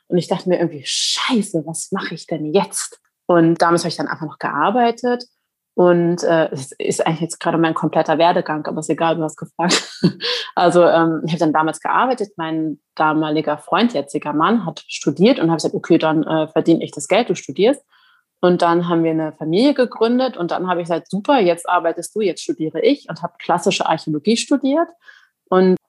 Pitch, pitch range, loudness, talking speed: 170 Hz, 160-195 Hz, -18 LUFS, 200 wpm